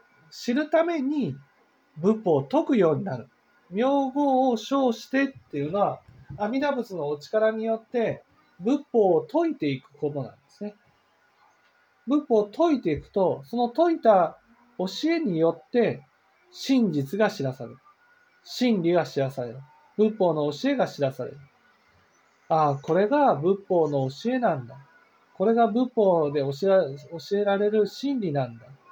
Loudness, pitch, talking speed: -25 LUFS, 210 Hz, 270 characters per minute